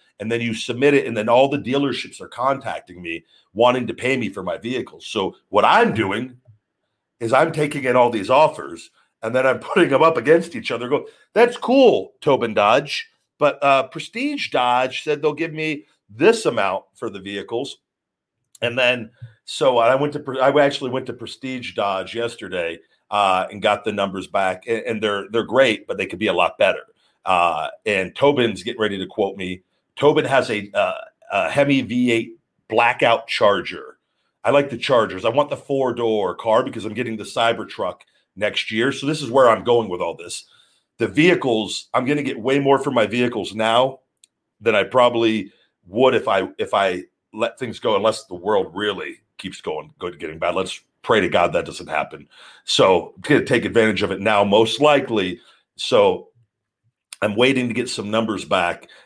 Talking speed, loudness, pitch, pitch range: 190 wpm, -19 LUFS, 125 Hz, 110-145 Hz